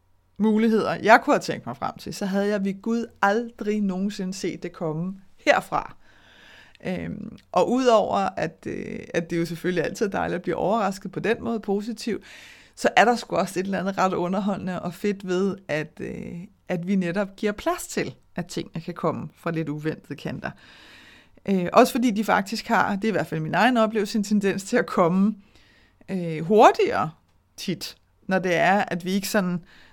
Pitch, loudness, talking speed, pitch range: 195 Hz, -24 LUFS, 190 wpm, 175-220 Hz